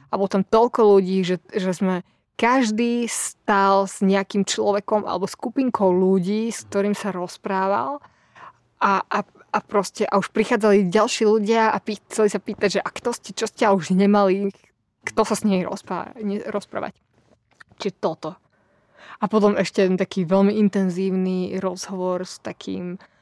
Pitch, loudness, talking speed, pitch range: 200 Hz, -21 LUFS, 160 wpm, 190-215 Hz